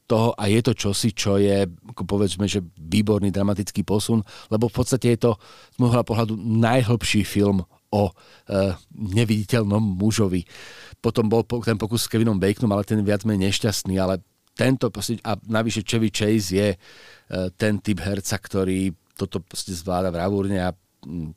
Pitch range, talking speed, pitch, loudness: 100-115 Hz, 155 wpm, 105 Hz, -23 LUFS